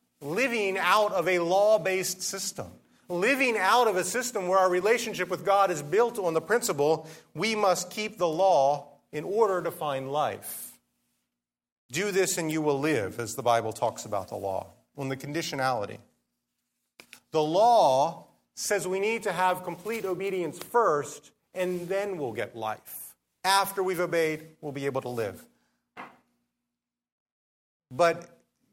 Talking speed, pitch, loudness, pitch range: 150 wpm, 170 Hz, -27 LUFS, 135-195 Hz